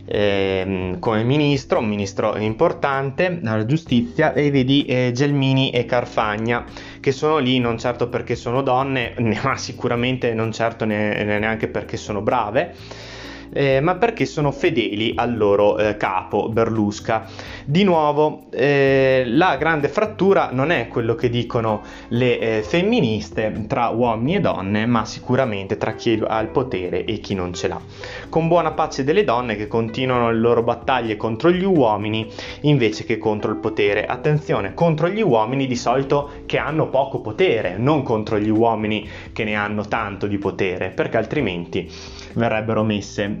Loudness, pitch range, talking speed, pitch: -20 LUFS, 105-135 Hz, 155 wpm, 120 Hz